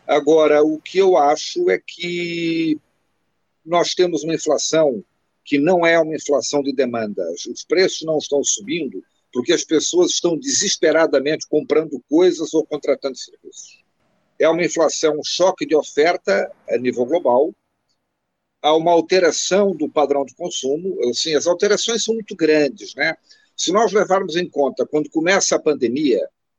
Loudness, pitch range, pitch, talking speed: -18 LUFS, 150-200 Hz, 165 Hz, 150 wpm